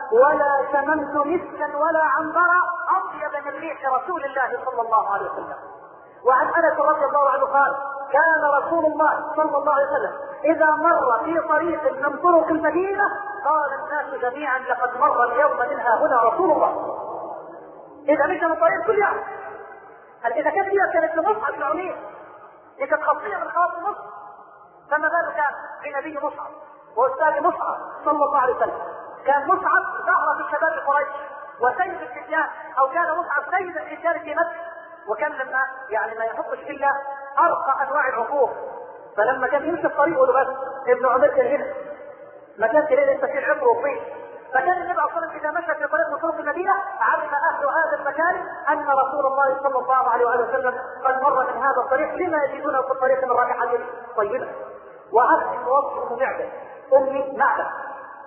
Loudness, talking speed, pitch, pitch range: -21 LUFS, 150 wpm, 290 Hz, 270-330 Hz